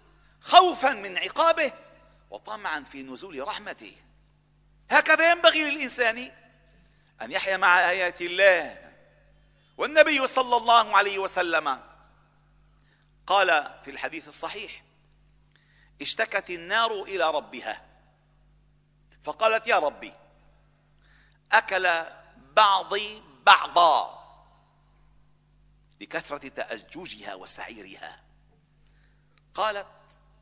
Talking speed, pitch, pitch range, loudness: 75 wpm, 180 Hz, 150-230 Hz, -23 LUFS